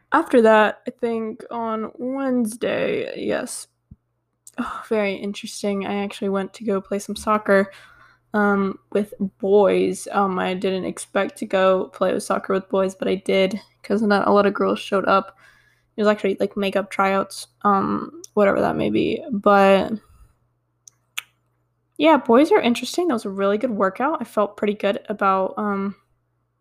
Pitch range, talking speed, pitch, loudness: 195-230 Hz, 160 wpm, 205 Hz, -21 LUFS